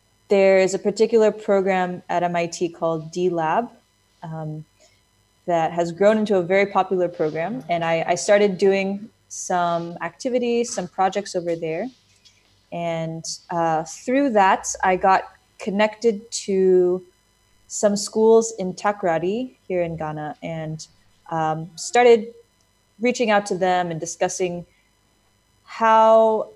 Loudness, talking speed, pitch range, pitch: -21 LUFS, 120 wpm, 160-205 Hz, 180 Hz